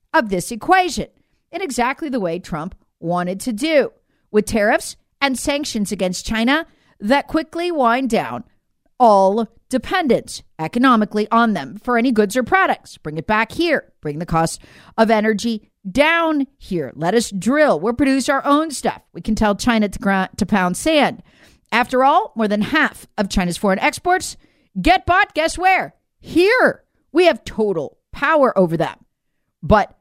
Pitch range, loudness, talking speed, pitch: 205-295 Hz, -18 LUFS, 160 wpm, 235 Hz